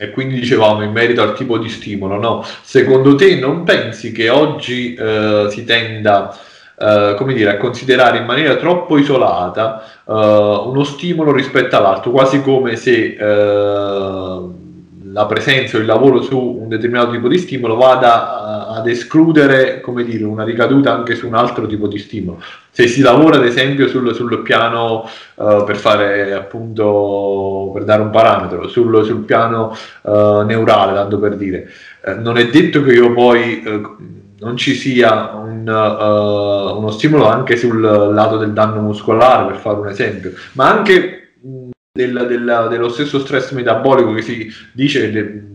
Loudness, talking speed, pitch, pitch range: -13 LUFS, 165 wpm, 115 Hz, 105-130 Hz